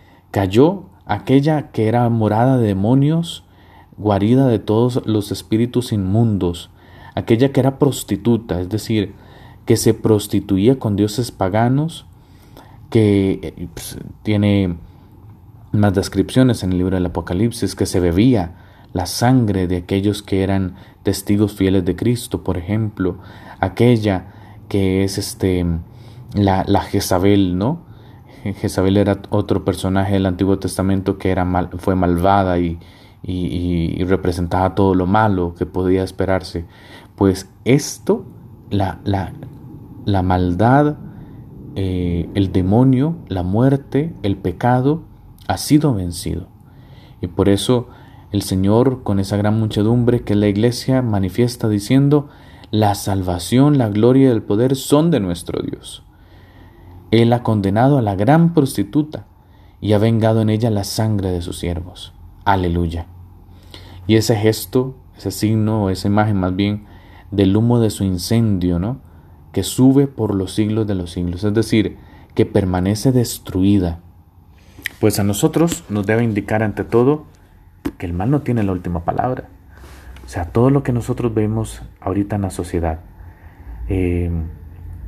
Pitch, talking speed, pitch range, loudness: 100 Hz, 140 wpm, 90-115 Hz, -17 LUFS